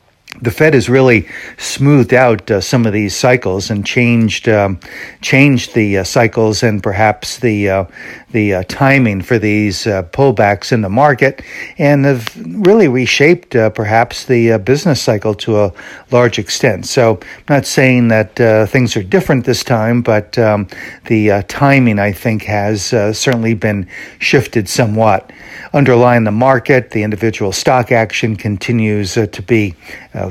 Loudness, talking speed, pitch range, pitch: -12 LUFS, 160 wpm, 105-125 Hz, 115 Hz